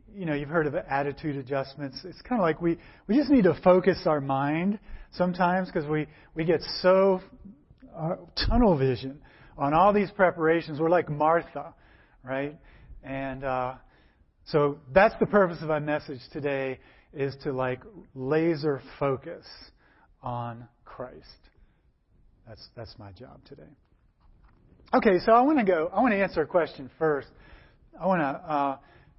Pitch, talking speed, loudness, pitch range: 150 Hz, 155 wpm, -26 LUFS, 135-180 Hz